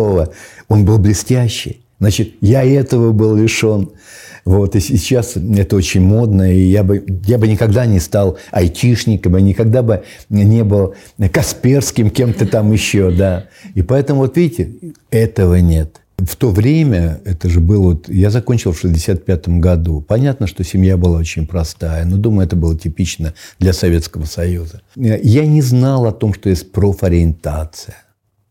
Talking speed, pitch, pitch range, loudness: 155 wpm, 100 Hz, 90-110 Hz, -14 LUFS